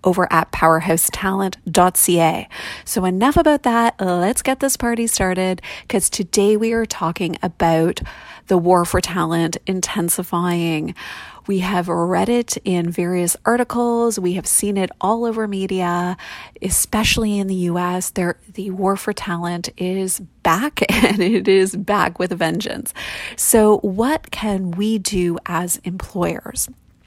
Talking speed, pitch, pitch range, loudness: 135 wpm, 185 Hz, 175-210 Hz, -18 LUFS